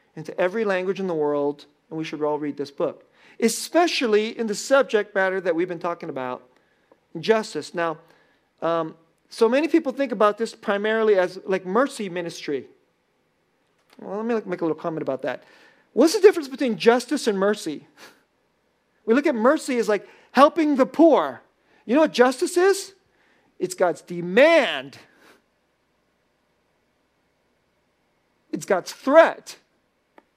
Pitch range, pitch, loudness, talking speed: 170-265 Hz, 210 Hz, -22 LUFS, 145 wpm